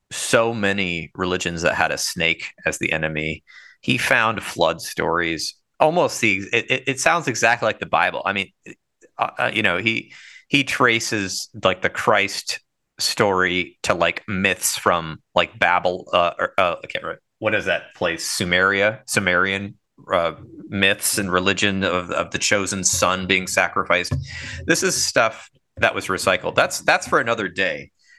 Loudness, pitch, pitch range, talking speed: -20 LUFS, 100 Hz, 90-110 Hz, 160 wpm